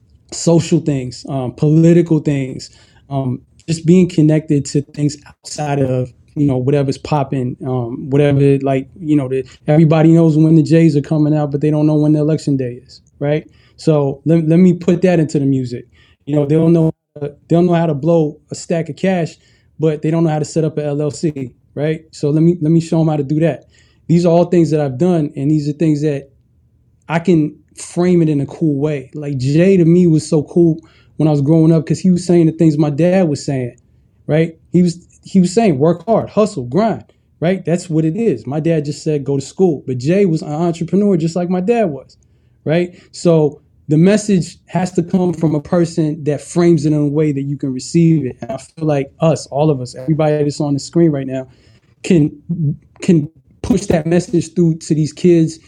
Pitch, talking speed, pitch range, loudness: 155 Hz, 220 wpm, 145-170 Hz, -15 LUFS